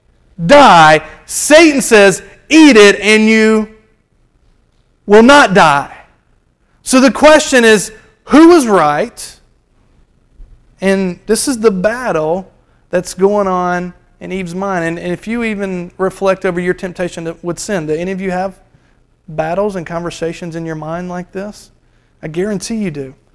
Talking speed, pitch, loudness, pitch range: 145 wpm, 190 Hz, -10 LUFS, 175-220 Hz